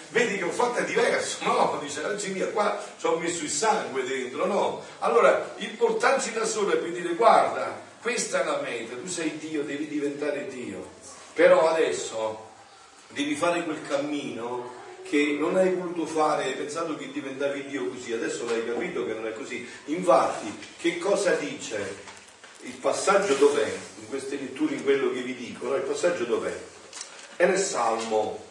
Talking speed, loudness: 175 wpm, -26 LUFS